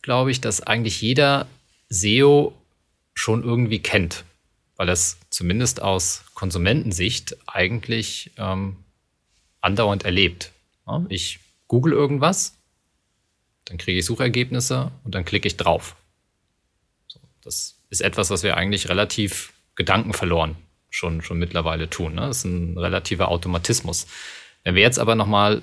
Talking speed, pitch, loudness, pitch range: 125 wpm, 100 Hz, -21 LUFS, 90-115 Hz